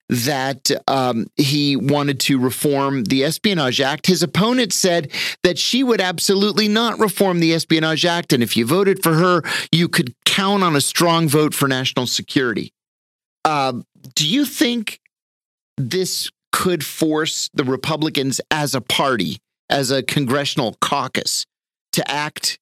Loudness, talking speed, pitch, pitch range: -18 LUFS, 145 wpm, 160 Hz, 140-185 Hz